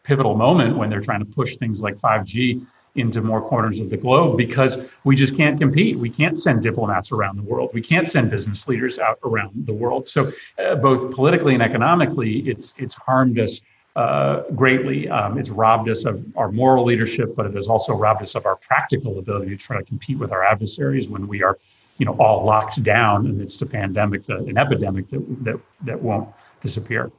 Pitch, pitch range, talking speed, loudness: 120 Hz, 105-130 Hz, 205 wpm, -19 LUFS